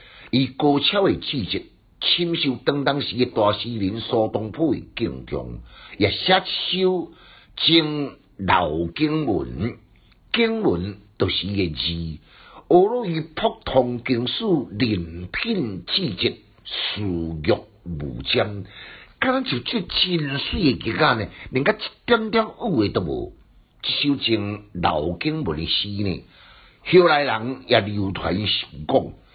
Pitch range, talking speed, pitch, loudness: 95-155 Hz, 180 characters per minute, 120 Hz, -22 LUFS